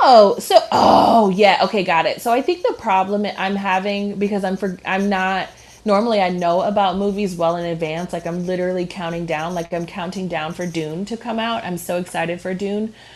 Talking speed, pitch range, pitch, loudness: 210 wpm, 175-205 Hz, 190 Hz, -19 LUFS